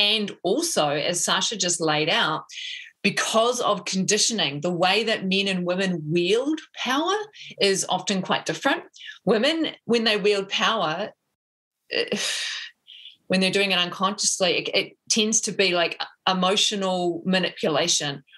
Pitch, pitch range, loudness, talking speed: 200 Hz, 185-245 Hz, -23 LUFS, 130 wpm